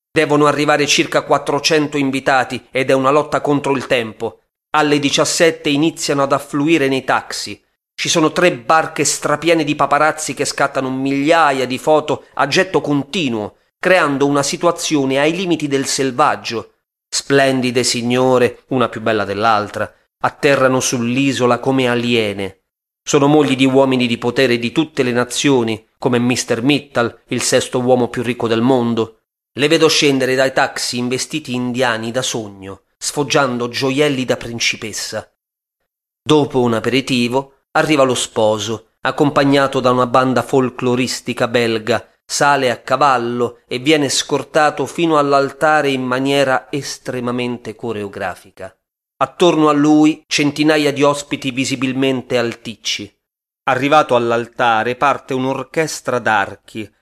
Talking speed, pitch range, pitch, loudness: 125 wpm, 120-145 Hz, 135 Hz, -16 LUFS